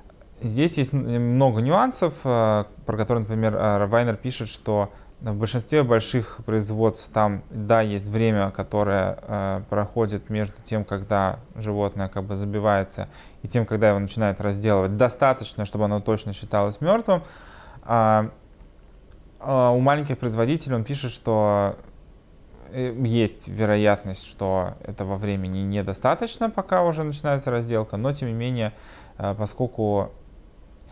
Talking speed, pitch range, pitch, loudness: 120 wpm, 100-120 Hz, 110 Hz, -24 LUFS